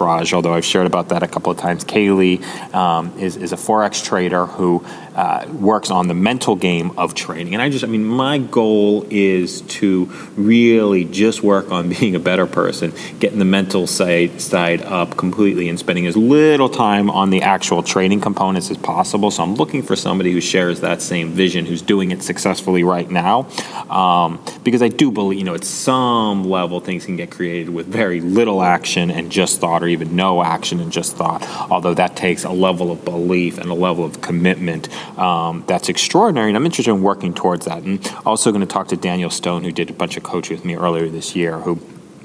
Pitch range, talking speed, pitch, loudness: 85-100 Hz, 210 wpm, 90 Hz, -17 LUFS